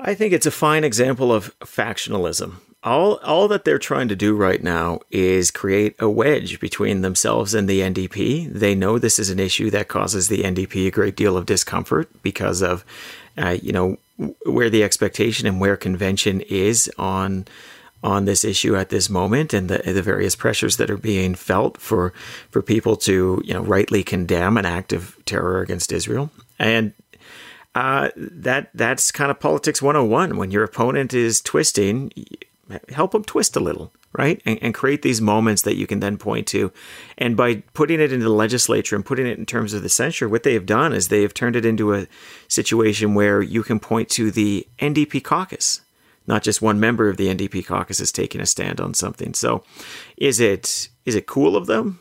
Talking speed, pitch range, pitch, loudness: 195 wpm, 95-120 Hz, 105 Hz, -19 LUFS